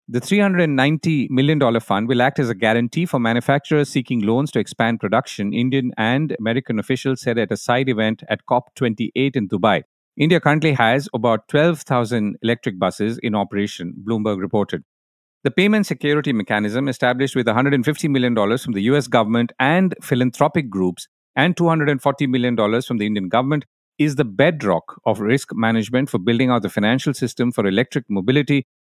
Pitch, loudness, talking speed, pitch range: 125 Hz, -19 LUFS, 160 wpm, 115-145 Hz